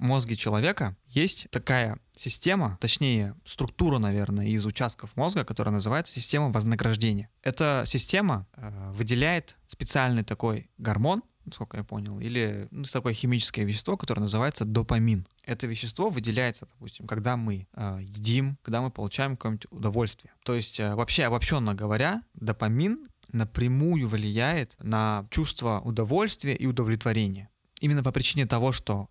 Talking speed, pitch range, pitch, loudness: 135 wpm, 105-135 Hz, 115 Hz, -27 LUFS